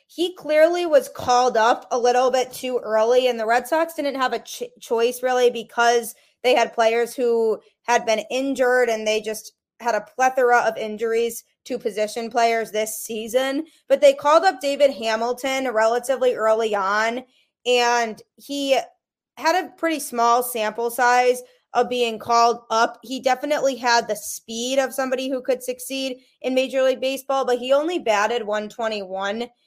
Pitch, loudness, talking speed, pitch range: 245 Hz, -21 LUFS, 165 wpm, 230-270 Hz